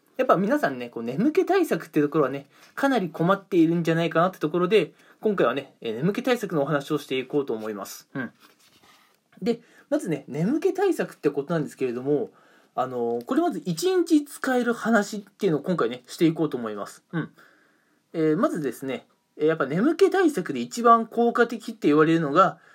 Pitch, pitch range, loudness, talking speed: 180 Hz, 145-240 Hz, -24 LUFS, 385 characters per minute